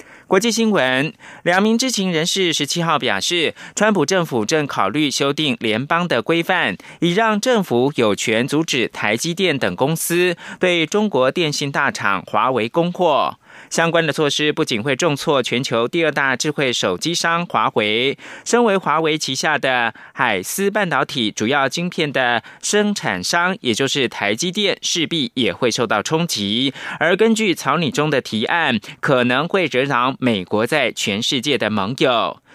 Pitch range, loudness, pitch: 135-180 Hz, -18 LUFS, 160 Hz